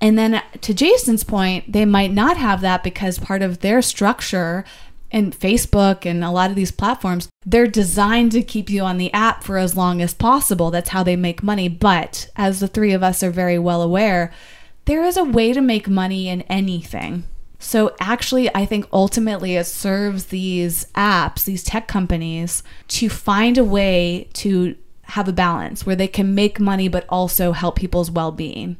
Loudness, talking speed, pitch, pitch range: -18 LUFS, 190 wpm, 195 Hz, 180-215 Hz